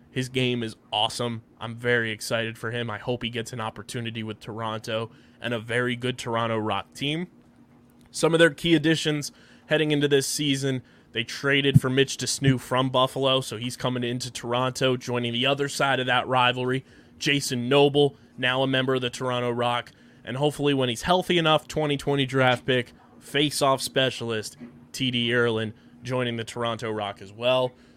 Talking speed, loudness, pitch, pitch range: 170 wpm, -25 LUFS, 125 Hz, 120-135 Hz